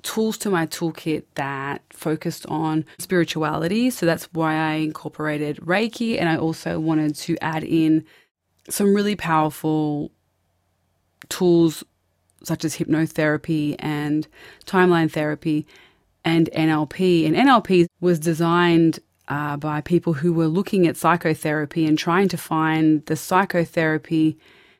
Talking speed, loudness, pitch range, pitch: 125 wpm, -21 LUFS, 155-170 Hz, 160 Hz